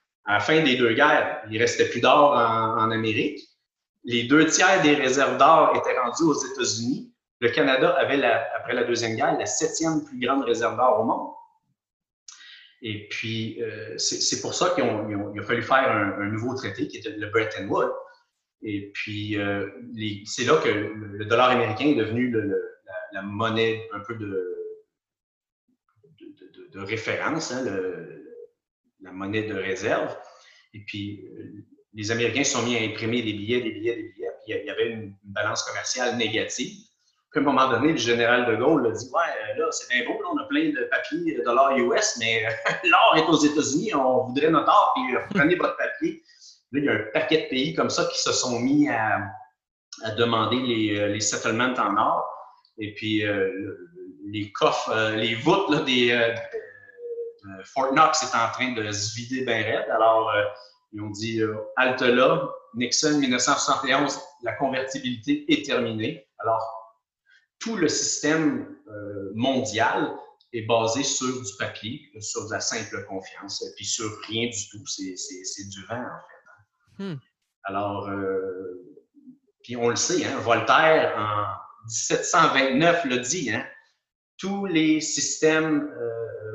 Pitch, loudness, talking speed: 125 Hz, -23 LUFS, 175 wpm